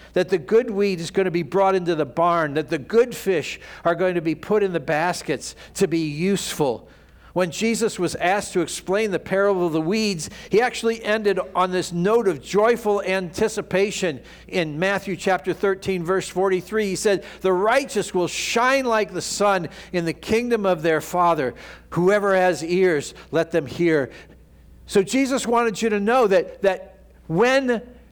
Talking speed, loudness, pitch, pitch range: 175 wpm, -22 LUFS, 190 Hz, 175-210 Hz